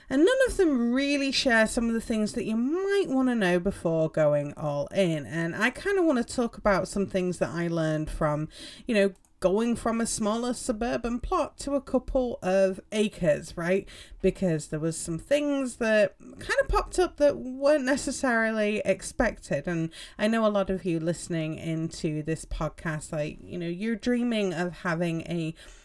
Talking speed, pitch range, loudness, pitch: 190 wpm, 170-255 Hz, -27 LUFS, 205 Hz